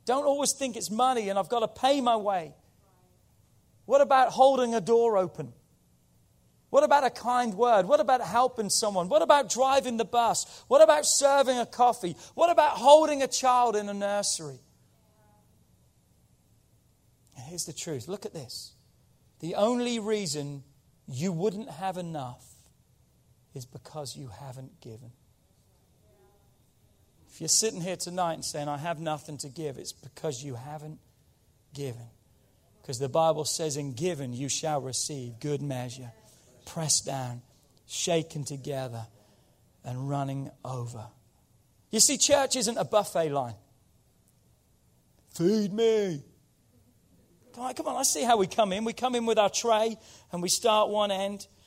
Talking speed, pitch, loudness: 145 wpm, 170 Hz, -26 LUFS